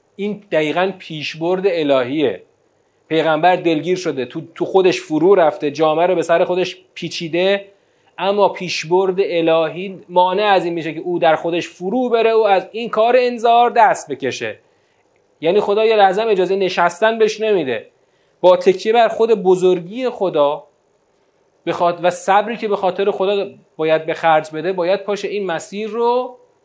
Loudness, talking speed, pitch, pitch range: -17 LUFS, 150 wpm, 190 Hz, 170-220 Hz